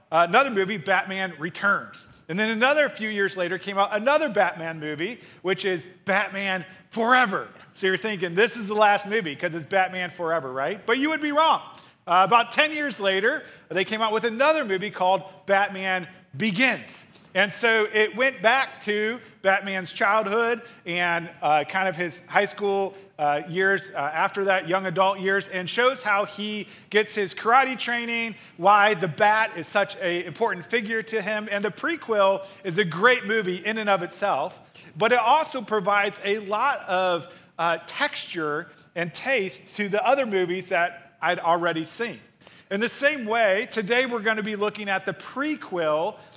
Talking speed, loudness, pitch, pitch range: 175 wpm, -24 LUFS, 195 Hz, 180-225 Hz